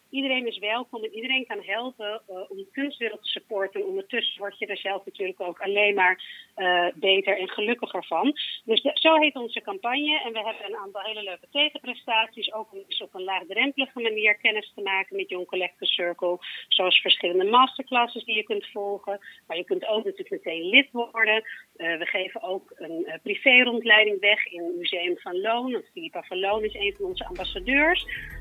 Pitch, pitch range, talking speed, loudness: 215 Hz, 195-255 Hz, 190 wpm, -24 LUFS